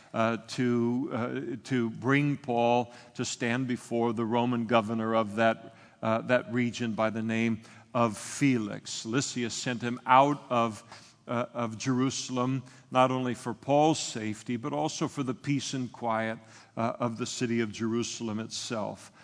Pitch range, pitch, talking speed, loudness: 115-130 Hz, 120 Hz, 155 wpm, -30 LUFS